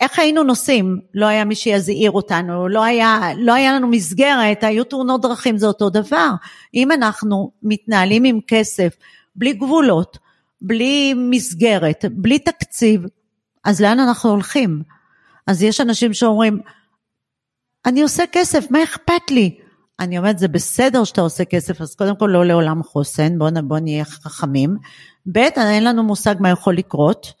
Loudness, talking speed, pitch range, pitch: -16 LUFS, 150 wpm, 185-245 Hz, 215 Hz